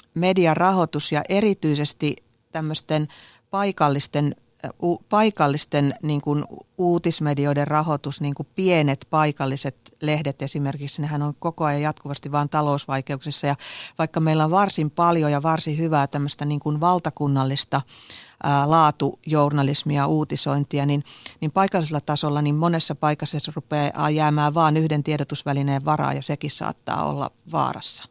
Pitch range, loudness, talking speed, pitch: 145-160 Hz, -22 LUFS, 120 wpm, 150 Hz